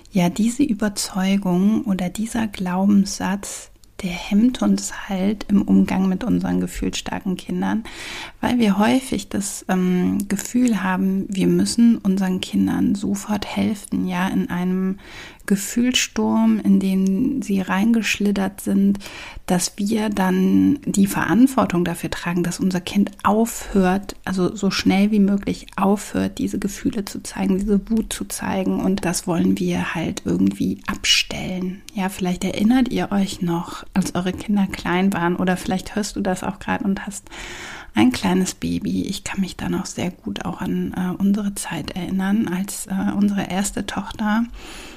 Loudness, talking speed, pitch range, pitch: -21 LUFS, 150 wpm, 180-210 Hz, 195 Hz